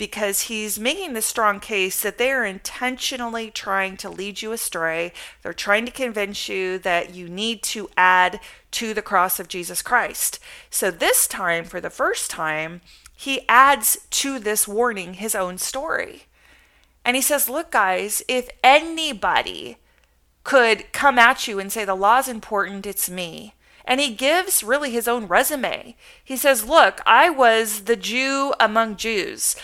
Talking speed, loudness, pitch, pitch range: 160 wpm, -20 LUFS, 225 Hz, 195-265 Hz